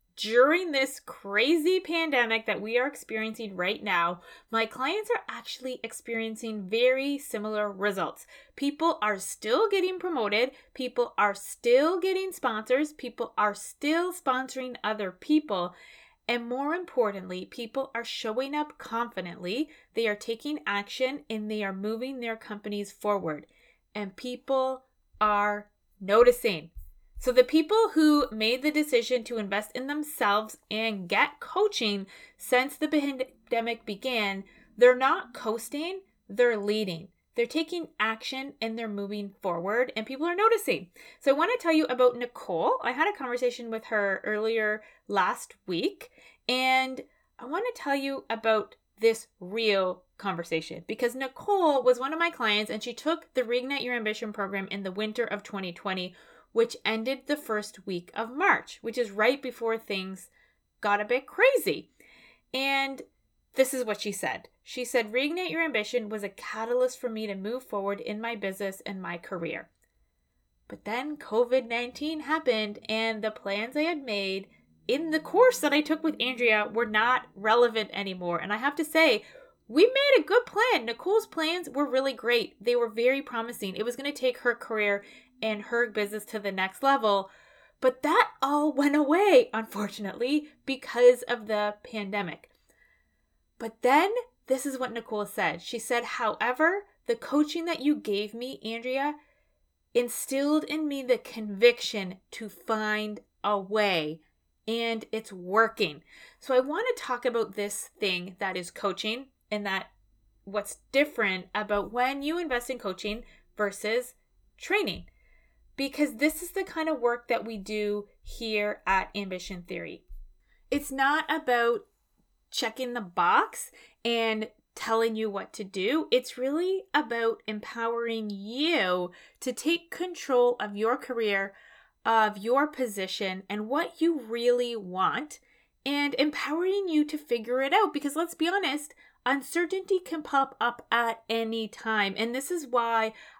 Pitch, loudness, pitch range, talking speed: 240 Hz, -28 LUFS, 210-285 Hz, 150 wpm